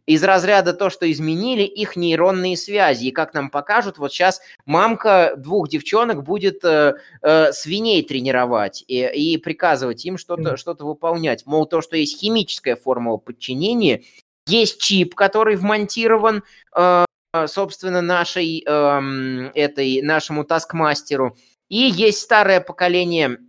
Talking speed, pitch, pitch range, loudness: 130 wpm, 170 Hz, 150-195 Hz, -18 LUFS